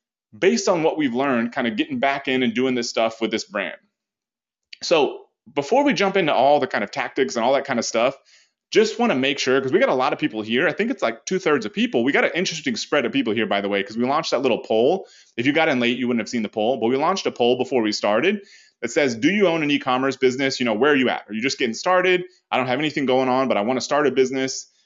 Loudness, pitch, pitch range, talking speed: -21 LUFS, 130 Hz, 120-180 Hz, 295 wpm